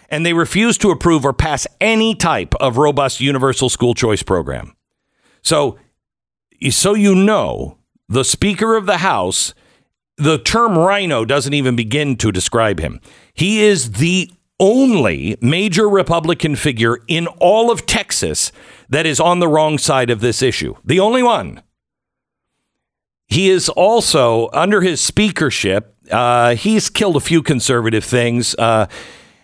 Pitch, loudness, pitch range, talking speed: 155 Hz, -14 LUFS, 125-190 Hz, 145 wpm